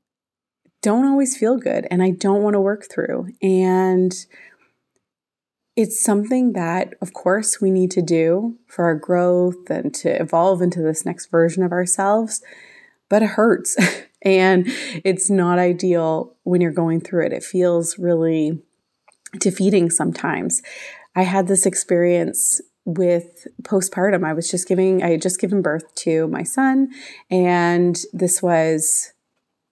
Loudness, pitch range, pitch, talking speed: -19 LUFS, 175-200 Hz, 185 Hz, 145 wpm